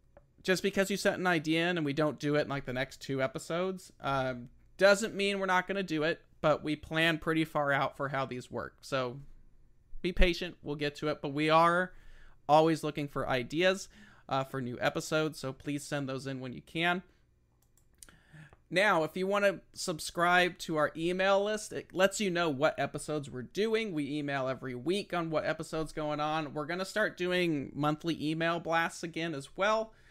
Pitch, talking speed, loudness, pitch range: 155 Hz, 200 wpm, -32 LUFS, 140-180 Hz